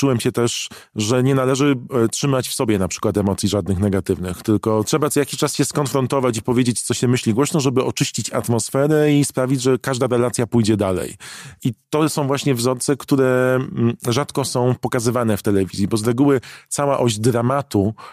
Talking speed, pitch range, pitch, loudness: 180 wpm, 115-140 Hz, 125 Hz, -19 LUFS